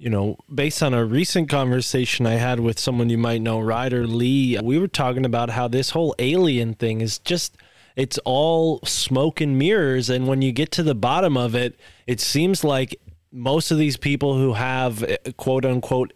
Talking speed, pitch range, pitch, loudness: 195 wpm, 120-145 Hz, 130 Hz, -21 LUFS